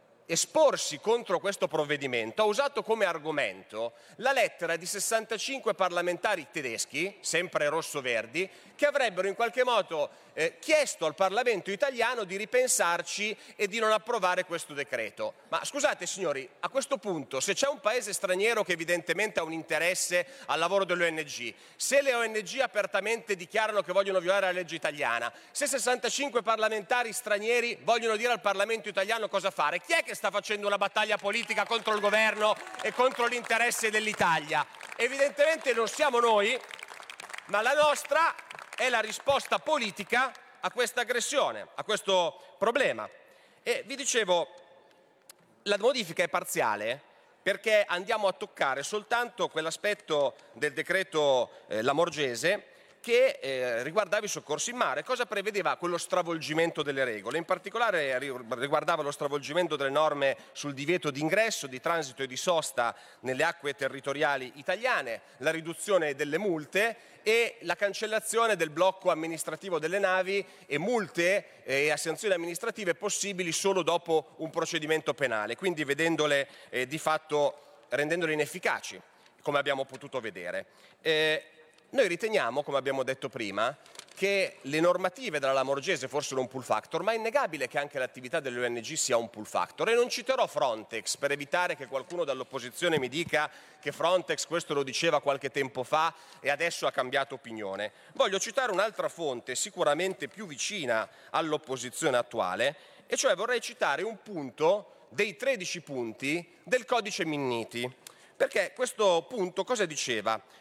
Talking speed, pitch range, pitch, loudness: 145 wpm, 150-220 Hz, 185 Hz, -29 LUFS